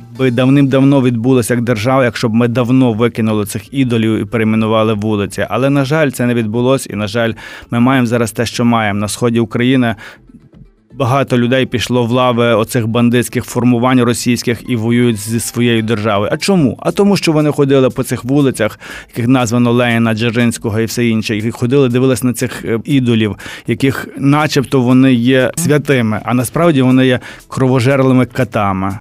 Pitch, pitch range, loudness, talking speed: 120 Hz, 115-130 Hz, -13 LUFS, 170 wpm